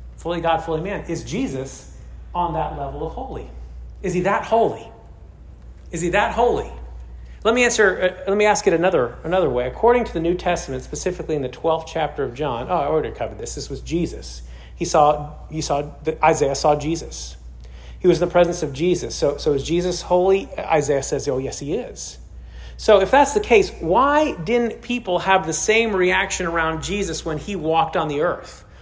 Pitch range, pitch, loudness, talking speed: 130-190 Hz, 165 Hz, -20 LUFS, 195 wpm